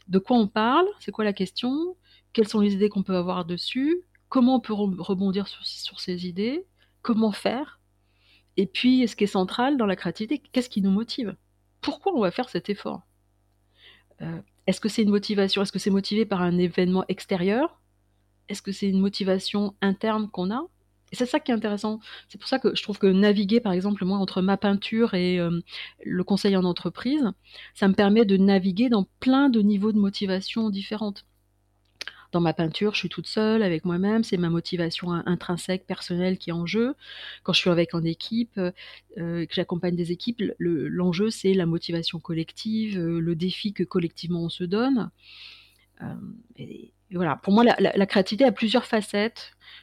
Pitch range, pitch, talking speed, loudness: 175-220 Hz, 195 Hz, 195 wpm, -25 LUFS